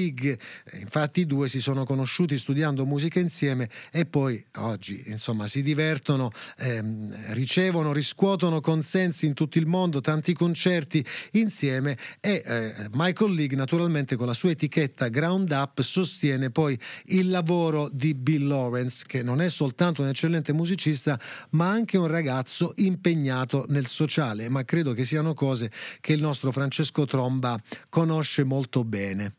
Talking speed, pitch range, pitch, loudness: 145 wpm, 130-165 Hz, 145 Hz, -26 LUFS